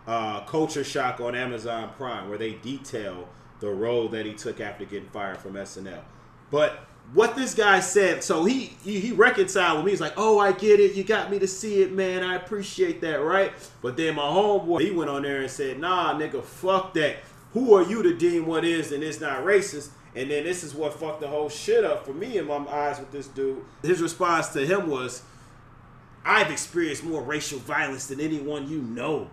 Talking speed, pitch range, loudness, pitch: 215 wpm, 130-190 Hz, -25 LUFS, 150 Hz